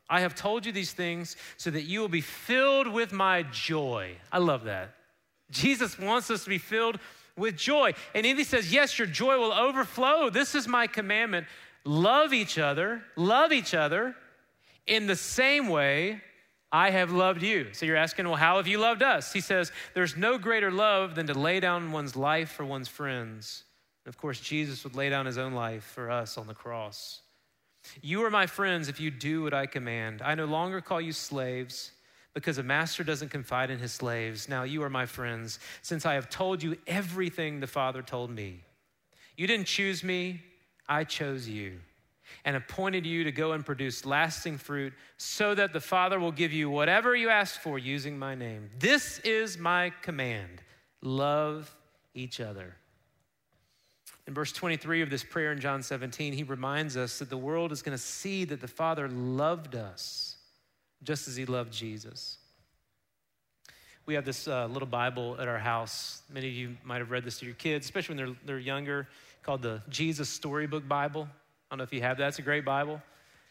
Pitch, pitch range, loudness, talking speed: 150 Hz, 130-185 Hz, -29 LUFS, 195 wpm